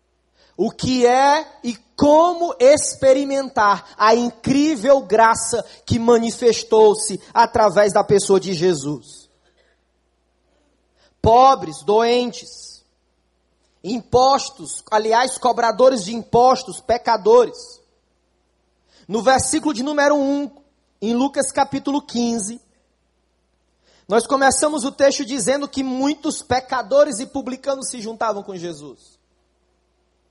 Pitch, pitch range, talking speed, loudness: 240 Hz, 200-275 Hz, 95 wpm, -17 LUFS